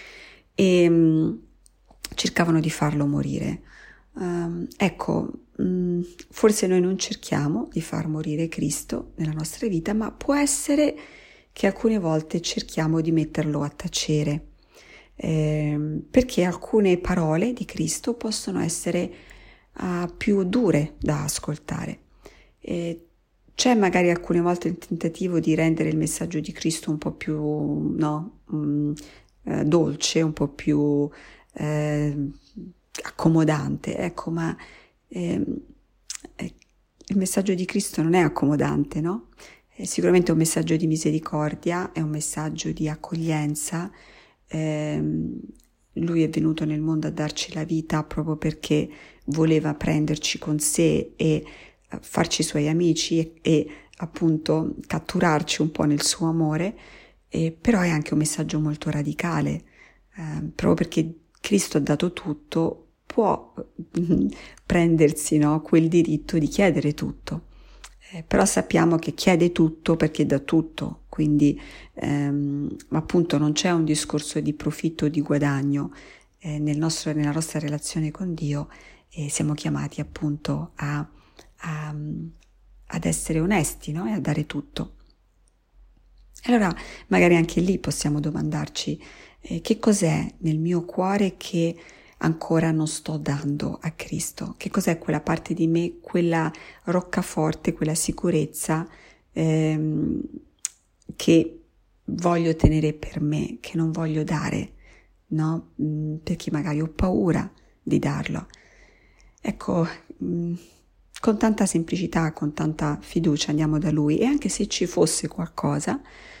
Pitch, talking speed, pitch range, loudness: 160 Hz, 125 wpm, 150-170 Hz, -24 LUFS